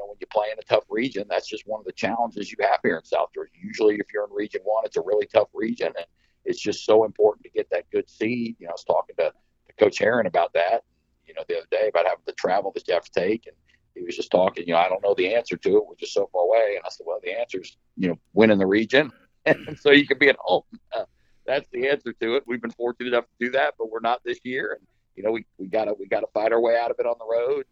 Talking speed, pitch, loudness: 295 wpm, 385 Hz, -24 LUFS